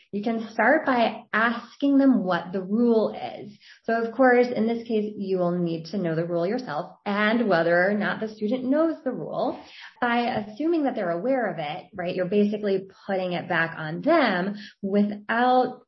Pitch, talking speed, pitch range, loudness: 215 Hz, 185 wpm, 190-245 Hz, -24 LUFS